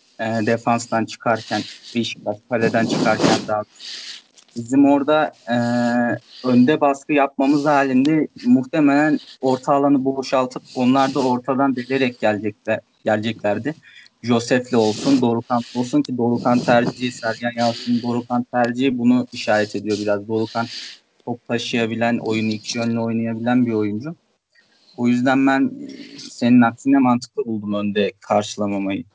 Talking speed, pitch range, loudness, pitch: 115 wpm, 115-135 Hz, -19 LUFS, 120 Hz